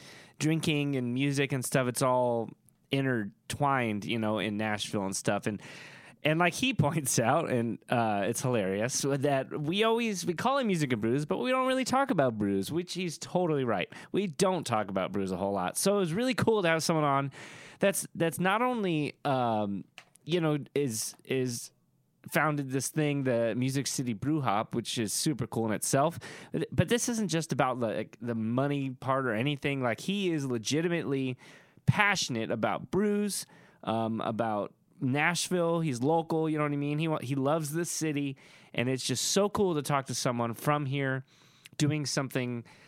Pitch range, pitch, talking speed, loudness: 125-165 Hz, 140 Hz, 185 wpm, -30 LUFS